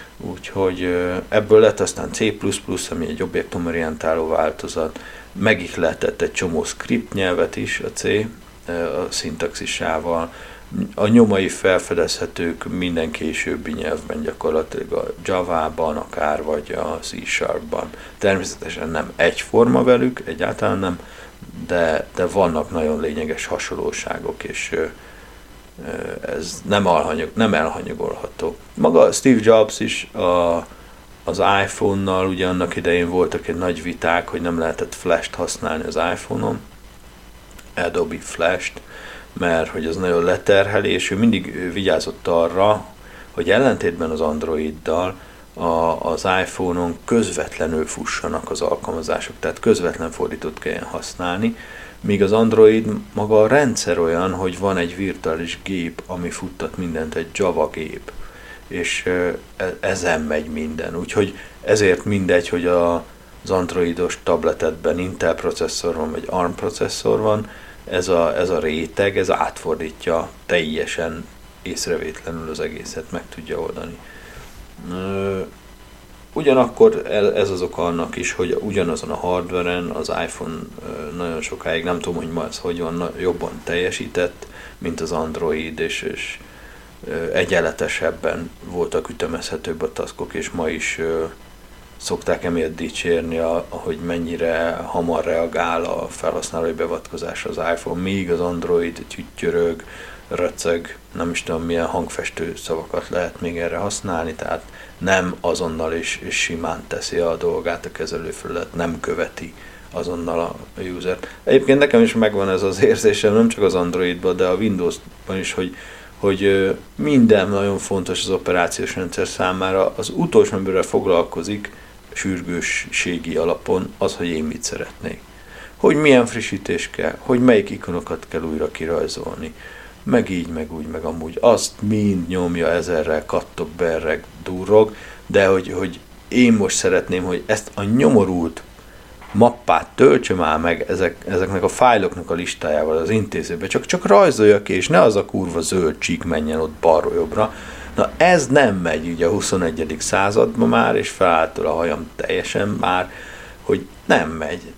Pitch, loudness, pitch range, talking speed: 90 Hz, -20 LUFS, 85-105 Hz, 135 wpm